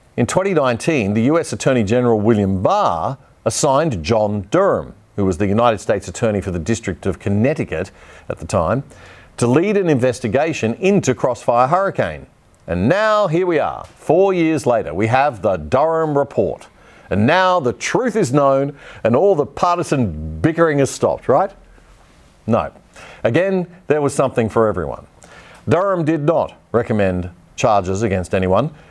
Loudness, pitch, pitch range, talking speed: -17 LUFS, 125 Hz, 105-160 Hz, 150 wpm